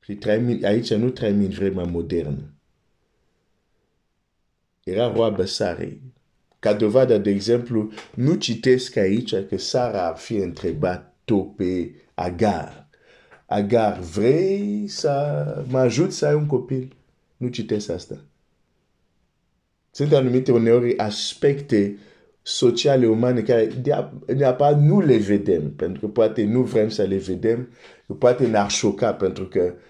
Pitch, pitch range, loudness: 115 Hz, 100-130 Hz, -21 LUFS